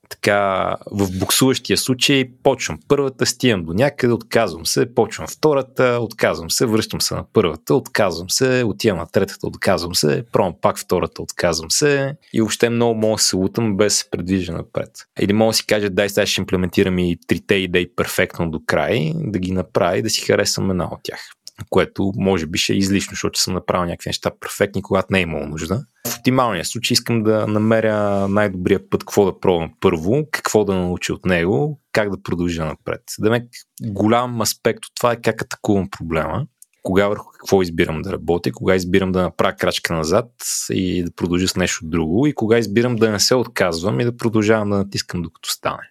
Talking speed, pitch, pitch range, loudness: 190 wpm, 105 Hz, 95-115 Hz, -19 LUFS